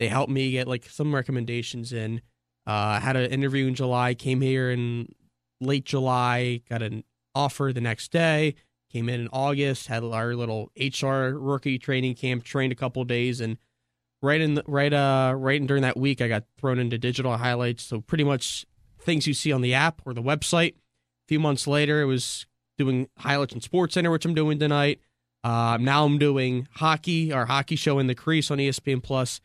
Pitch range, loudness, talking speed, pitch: 120-140 Hz, -25 LUFS, 200 wpm, 130 Hz